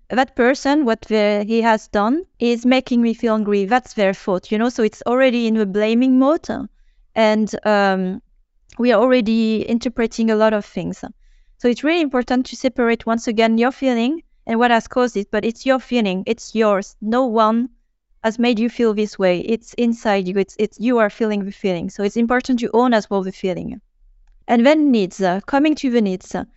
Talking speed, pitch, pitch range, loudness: 210 wpm, 230 Hz, 210-245 Hz, -18 LUFS